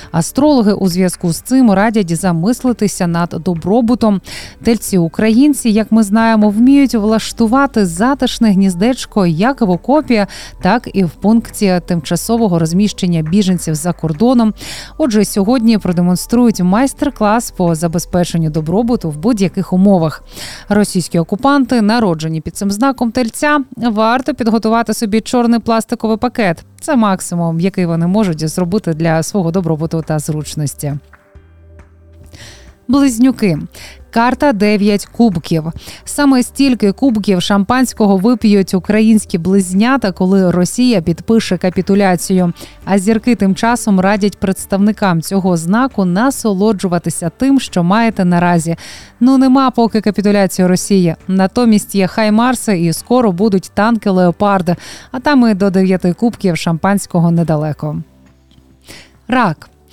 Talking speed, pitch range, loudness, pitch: 115 wpm, 175-230 Hz, -13 LUFS, 200 Hz